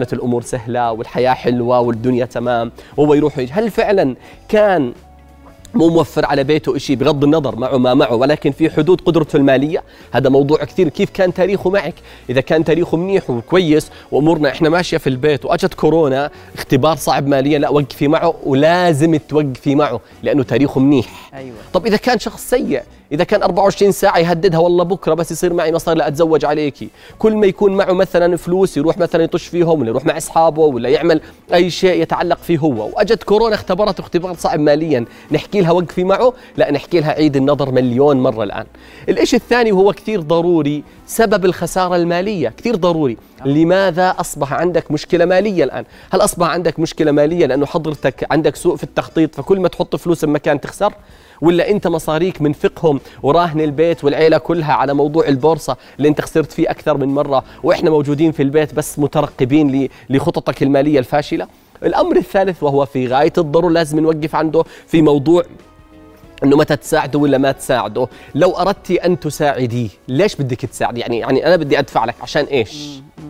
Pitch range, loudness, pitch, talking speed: 140-175 Hz, -15 LUFS, 155 Hz, 170 wpm